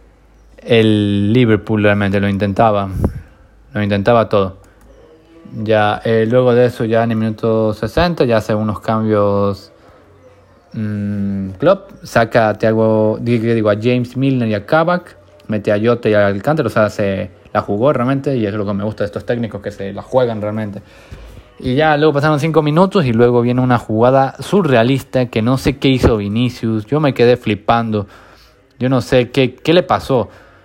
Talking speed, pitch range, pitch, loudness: 175 wpm, 105-125 Hz, 110 Hz, -15 LUFS